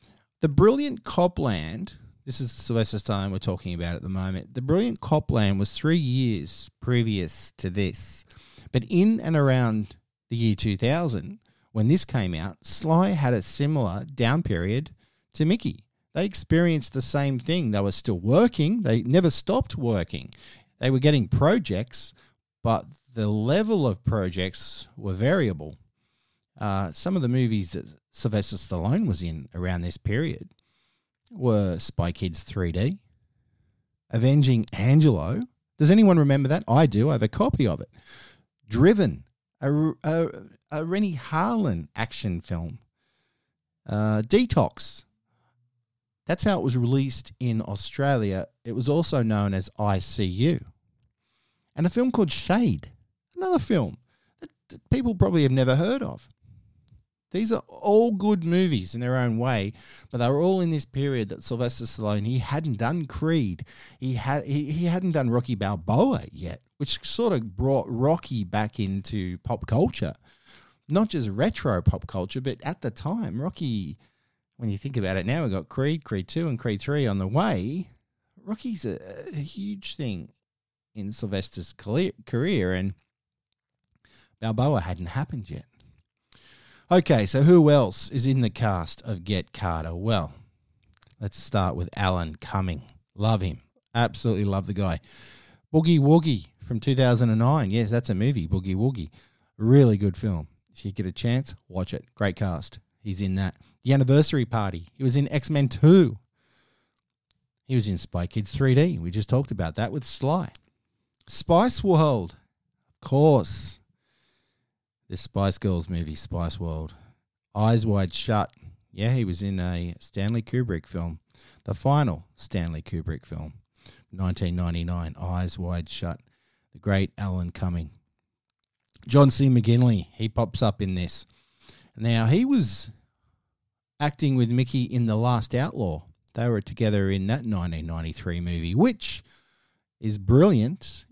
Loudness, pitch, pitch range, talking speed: -25 LUFS, 115 Hz, 100-140 Hz, 150 wpm